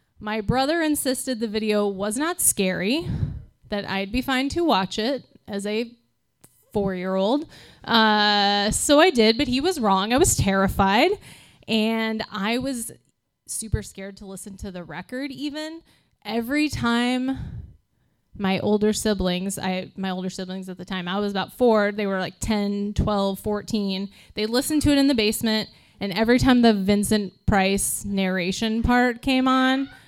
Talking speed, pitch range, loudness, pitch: 160 wpm, 195-255 Hz, -22 LUFS, 215 Hz